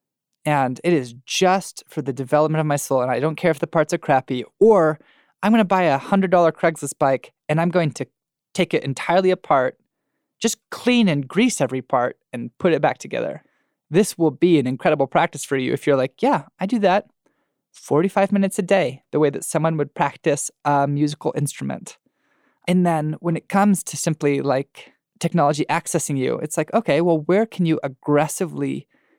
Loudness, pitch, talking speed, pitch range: -20 LUFS, 155 Hz, 195 wpm, 140-180 Hz